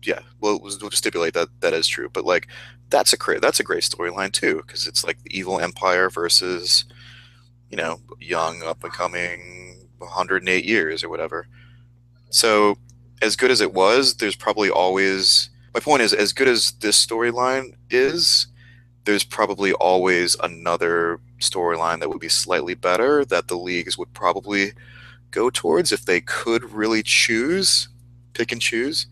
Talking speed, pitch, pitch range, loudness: 165 wpm, 115 Hz, 95-120 Hz, -20 LUFS